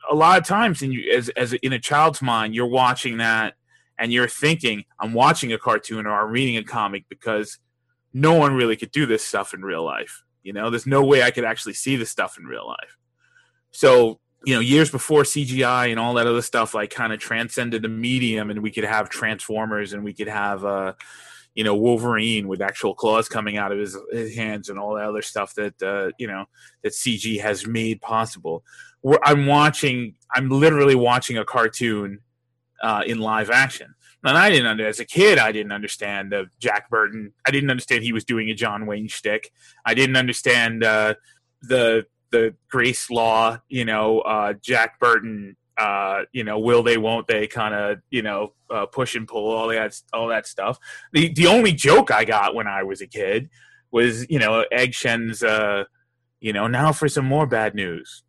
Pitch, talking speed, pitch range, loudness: 115 Hz, 200 wpm, 110-130 Hz, -20 LUFS